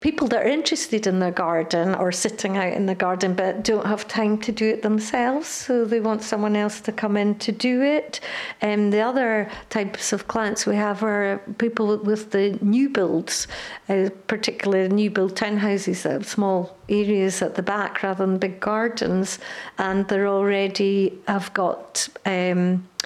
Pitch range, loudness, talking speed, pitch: 190-220 Hz, -23 LUFS, 180 wpm, 205 Hz